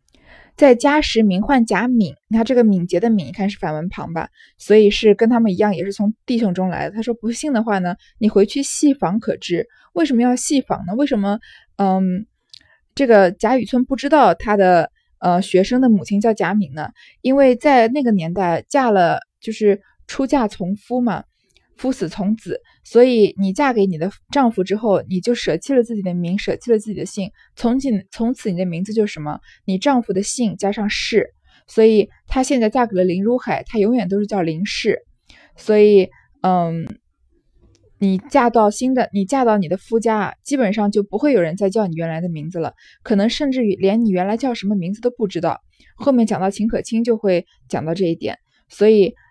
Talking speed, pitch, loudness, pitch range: 285 characters per minute, 210 Hz, -18 LUFS, 190-240 Hz